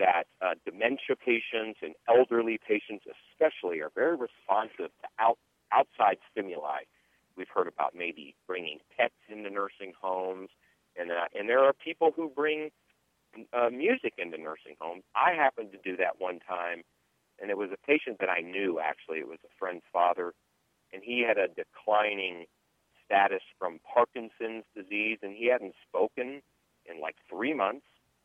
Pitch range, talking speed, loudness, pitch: 95-135 Hz, 160 wpm, -30 LUFS, 110 Hz